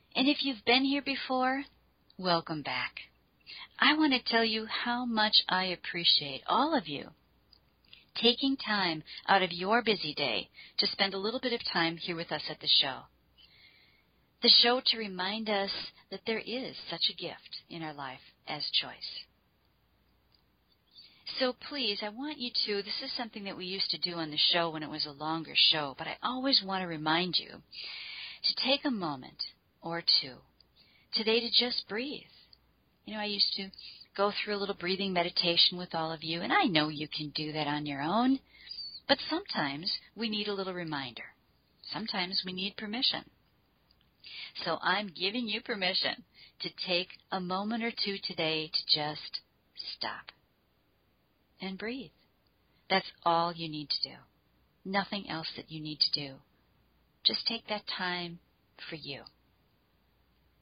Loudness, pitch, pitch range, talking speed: -30 LUFS, 190 Hz, 160-225 Hz, 165 wpm